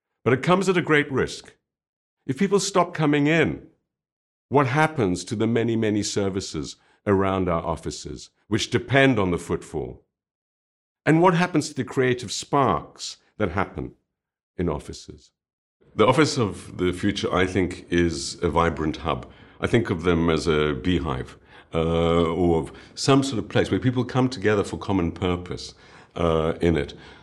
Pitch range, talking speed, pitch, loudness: 85-130 Hz, 160 wpm, 95 Hz, -23 LUFS